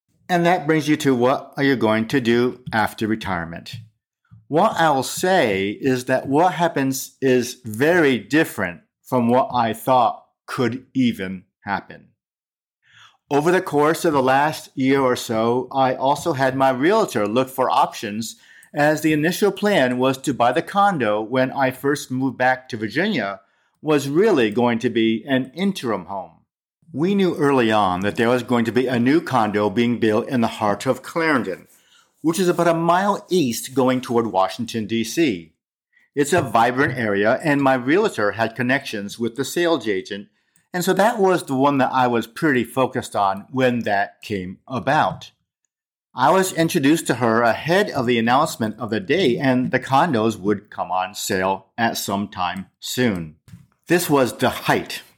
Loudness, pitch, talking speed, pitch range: -20 LUFS, 130 Hz, 170 wpm, 115-155 Hz